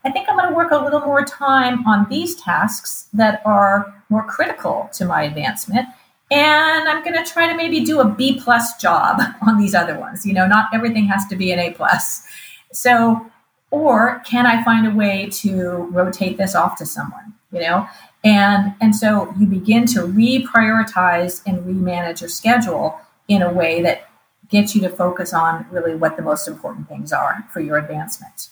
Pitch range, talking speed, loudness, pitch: 185-245 Hz, 190 wpm, -17 LUFS, 210 Hz